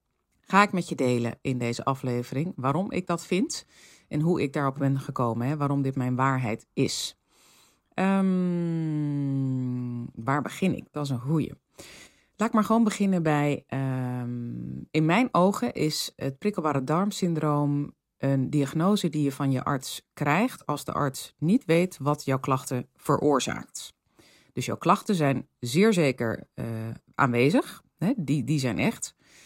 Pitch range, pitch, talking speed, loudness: 130-175 Hz, 145 Hz, 155 wpm, -27 LUFS